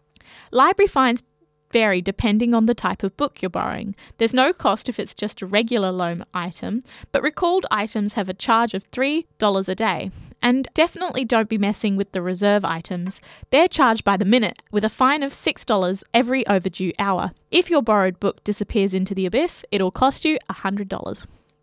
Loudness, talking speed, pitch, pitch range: -21 LUFS, 190 wpm, 210 Hz, 195-255 Hz